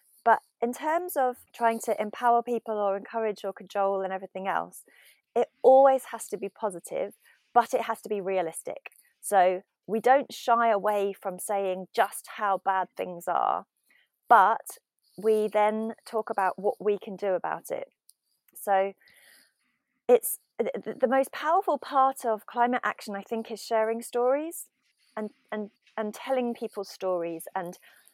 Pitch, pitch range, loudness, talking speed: 220 Hz, 195-245 Hz, -27 LUFS, 150 wpm